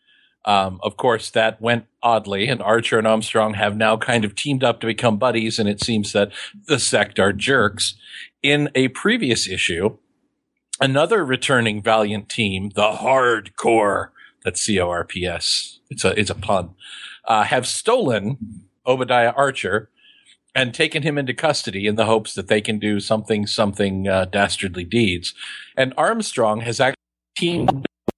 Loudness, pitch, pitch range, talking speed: -19 LUFS, 110 Hz, 105-130 Hz, 160 wpm